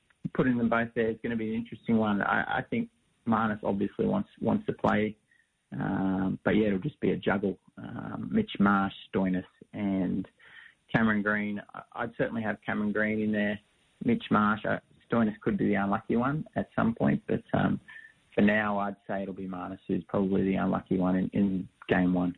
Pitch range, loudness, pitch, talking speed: 95-115 Hz, -29 LUFS, 105 Hz, 195 wpm